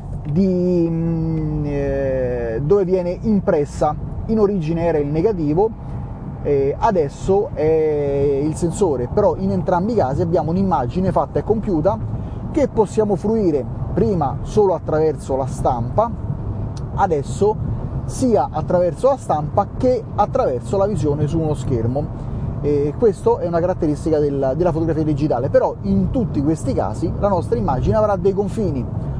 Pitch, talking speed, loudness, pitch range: 155 Hz, 135 wpm, -19 LUFS, 140-185 Hz